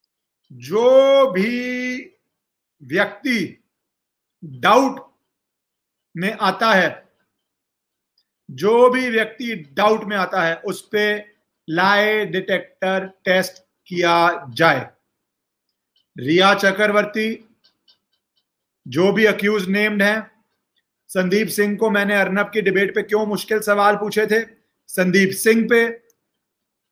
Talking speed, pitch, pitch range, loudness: 100 wpm, 205 Hz, 190-220 Hz, -18 LUFS